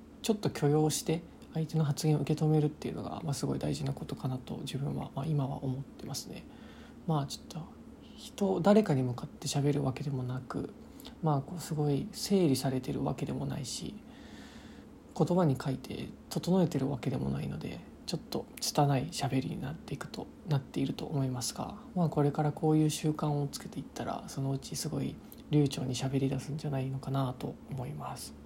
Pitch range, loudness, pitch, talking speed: 135-155 Hz, -33 LUFS, 145 Hz, 315 characters per minute